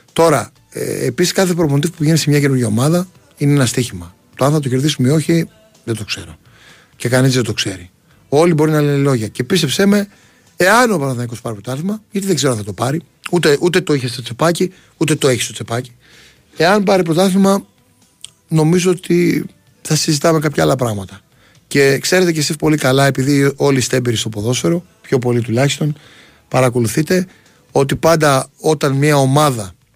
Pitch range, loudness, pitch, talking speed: 125-165 Hz, -15 LUFS, 145 Hz, 180 wpm